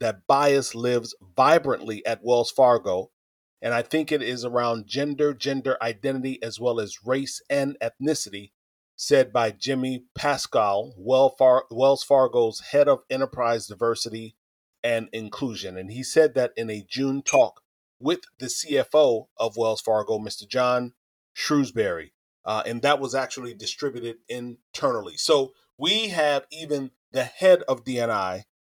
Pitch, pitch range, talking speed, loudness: 130 Hz, 115-140 Hz, 140 wpm, -24 LUFS